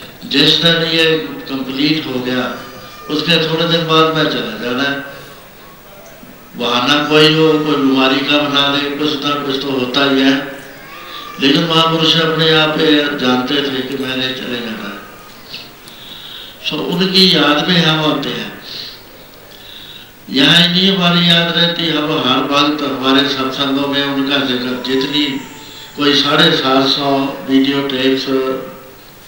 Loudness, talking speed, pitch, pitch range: -13 LUFS, 145 wpm, 145 Hz, 135-155 Hz